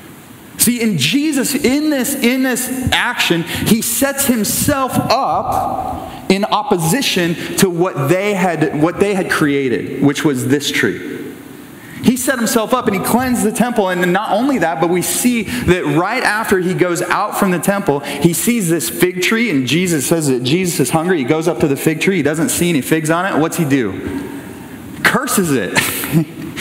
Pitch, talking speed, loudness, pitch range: 185 Hz, 185 wpm, -15 LUFS, 160-235 Hz